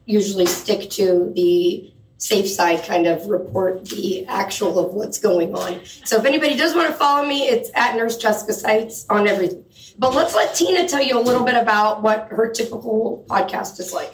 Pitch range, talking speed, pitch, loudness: 195-280 Hz, 195 wpm, 220 Hz, -19 LUFS